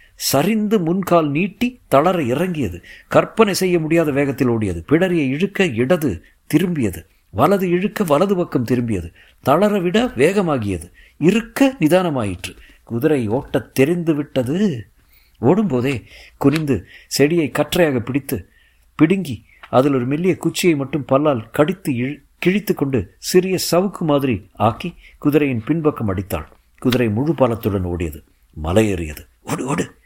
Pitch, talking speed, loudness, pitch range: 145 Hz, 110 wpm, -18 LUFS, 115-175 Hz